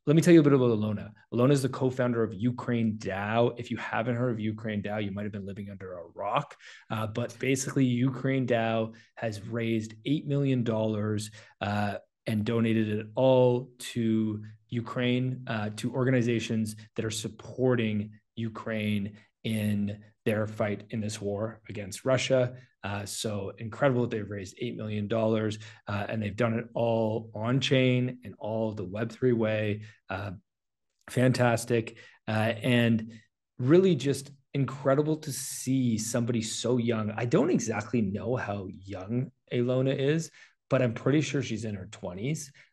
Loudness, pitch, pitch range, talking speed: -29 LUFS, 115 Hz, 105-125 Hz, 155 wpm